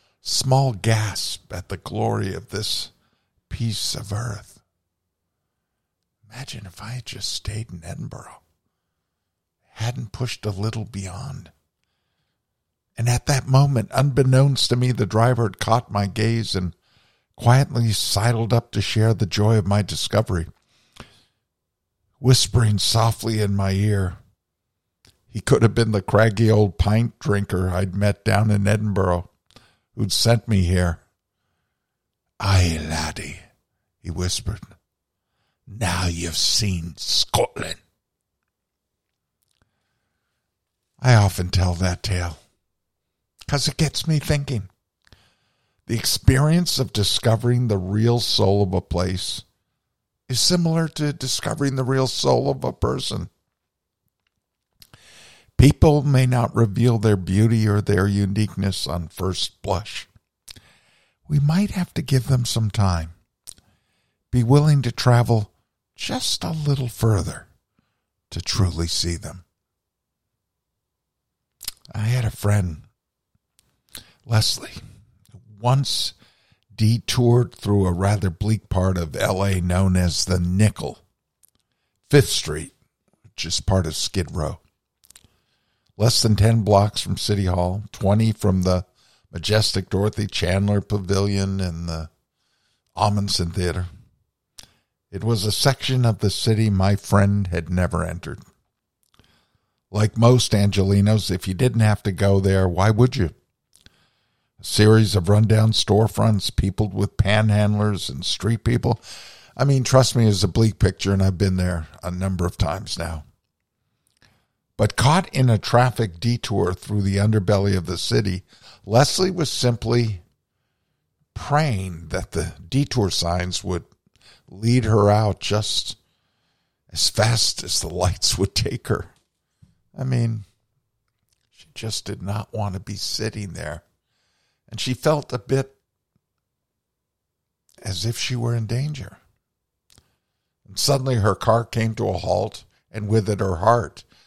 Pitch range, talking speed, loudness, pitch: 95-120 Hz, 125 wpm, -21 LUFS, 105 Hz